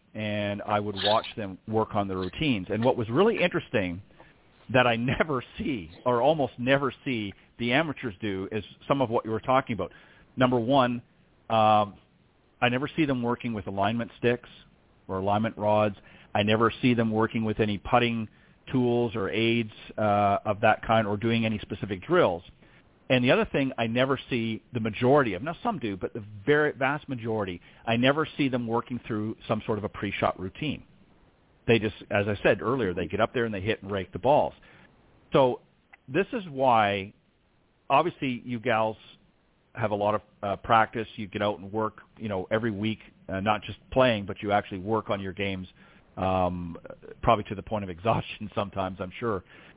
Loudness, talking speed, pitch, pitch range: -27 LUFS, 190 wpm, 110 Hz, 100-120 Hz